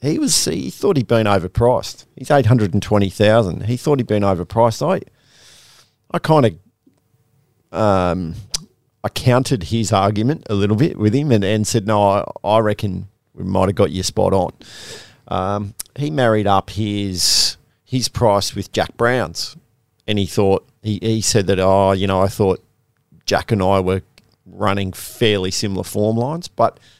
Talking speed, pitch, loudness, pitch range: 175 wpm, 105 Hz, -18 LUFS, 100-120 Hz